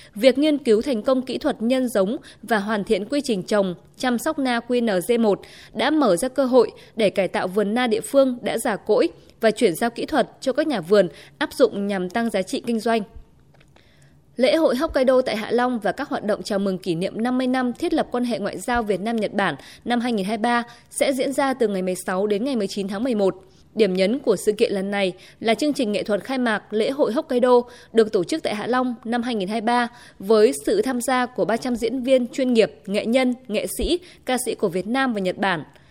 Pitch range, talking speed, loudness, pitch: 205-260 Hz, 225 wpm, -22 LUFS, 235 Hz